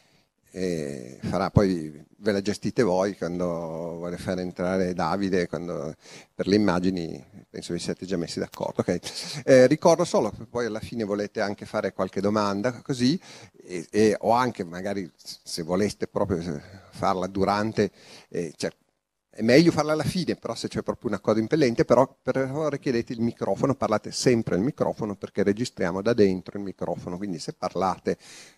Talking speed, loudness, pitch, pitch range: 165 wpm, -26 LUFS, 100 Hz, 90-120 Hz